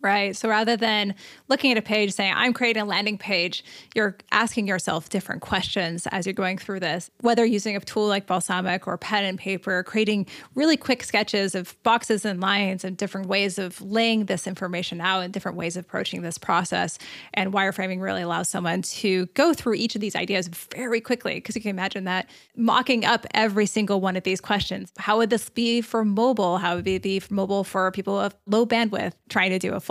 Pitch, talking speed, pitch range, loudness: 200 Hz, 215 wpm, 185-220 Hz, -24 LUFS